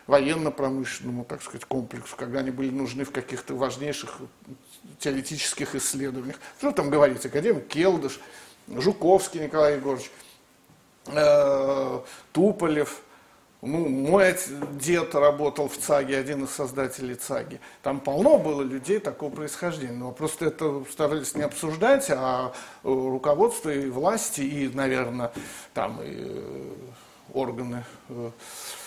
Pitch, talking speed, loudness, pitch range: 145 Hz, 115 wpm, -26 LUFS, 135-155 Hz